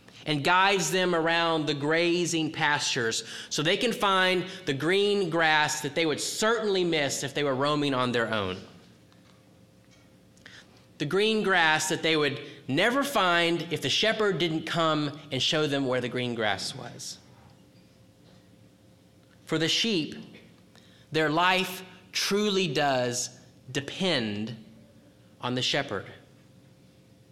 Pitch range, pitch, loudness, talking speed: 130-180 Hz, 155 Hz, -26 LUFS, 125 wpm